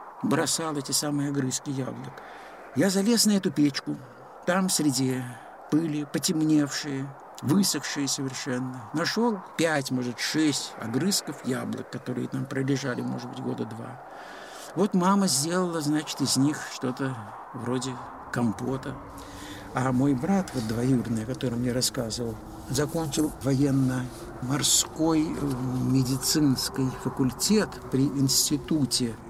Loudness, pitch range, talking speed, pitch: -26 LUFS, 125-155 Hz, 110 wpm, 135 Hz